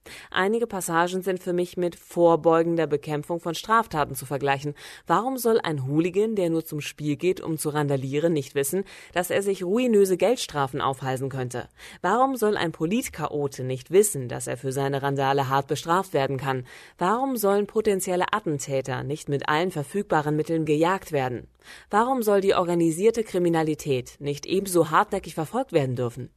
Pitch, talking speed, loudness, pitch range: 165 Hz, 160 wpm, -25 LUFS, 140-190 Hz